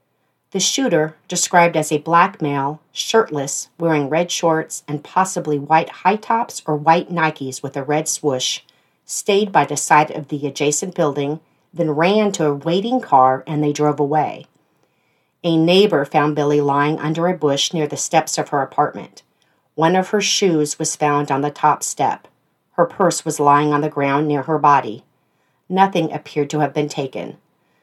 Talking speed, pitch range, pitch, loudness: 175 wpm, 145-170 Hz, 155 Hz, -18 LUFS